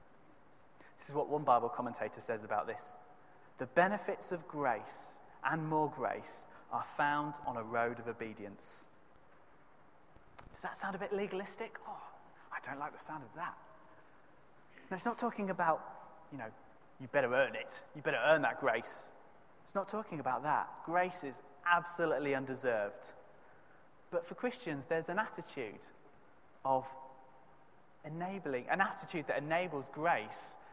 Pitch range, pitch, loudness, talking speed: 135-190 Hz, 165 Hz, -37 LUFS, 145 wpm